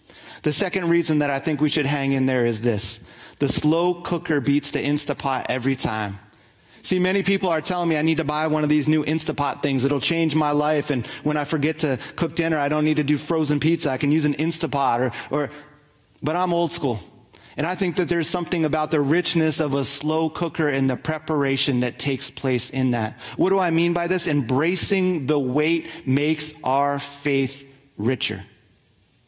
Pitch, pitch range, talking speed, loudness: 150 Hz, 135-160 Hz, 205 wpm, -22 LUFS